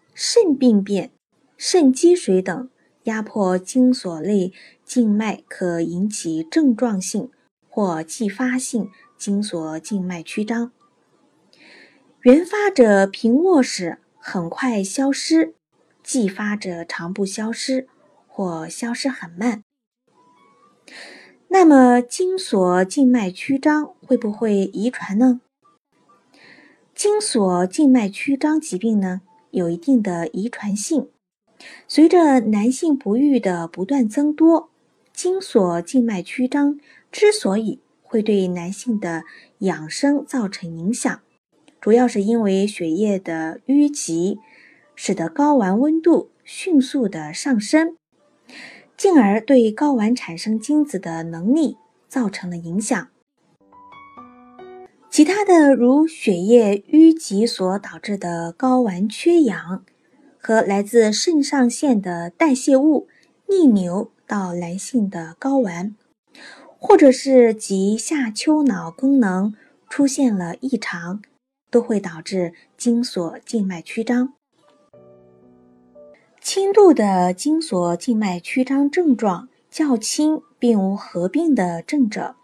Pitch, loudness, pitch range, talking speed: 235 Hz, -19 LUFS, 190-280 Hz, 165 characters per minute